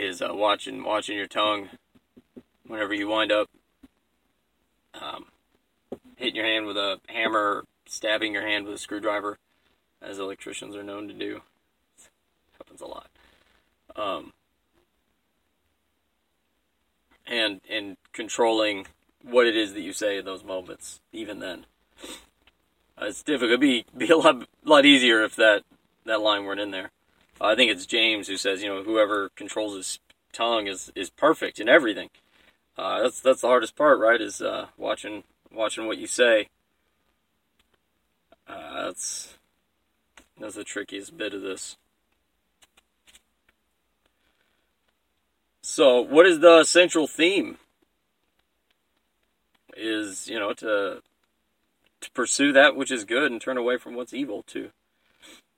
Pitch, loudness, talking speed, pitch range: 105 Hz, -23 LUFS, 140 wpm, 100-120 Hz